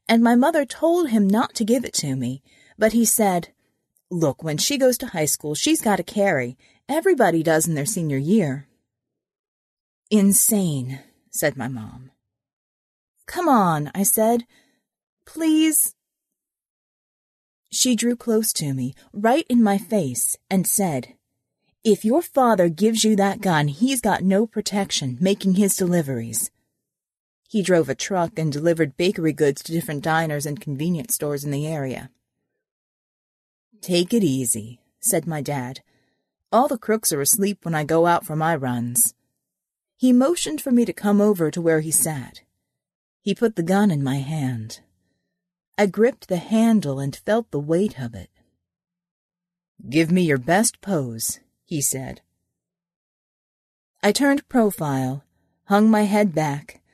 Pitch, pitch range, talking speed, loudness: 175 Hz, 145-220 Hz, 150 wpm, -21 LUFS